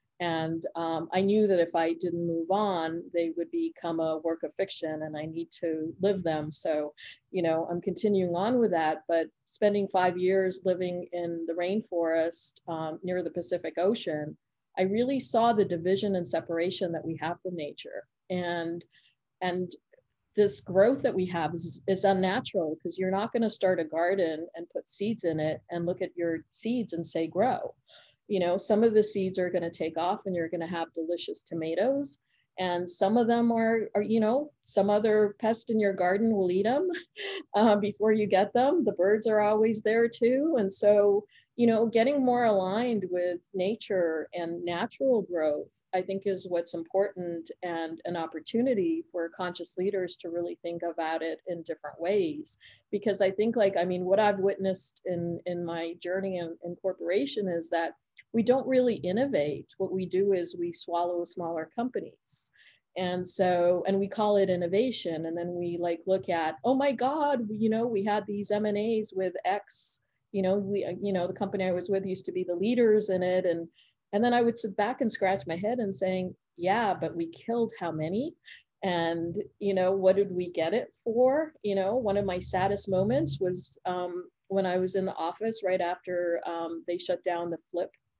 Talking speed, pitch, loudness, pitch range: 195 wpm, 185 Hz, -29 LUFS, 170-210 Hz